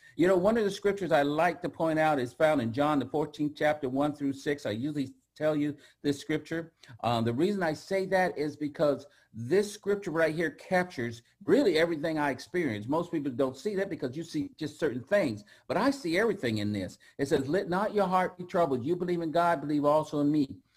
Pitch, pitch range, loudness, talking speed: 155 Hz, 140-180 Hz, -29 LUFS, 220 wpm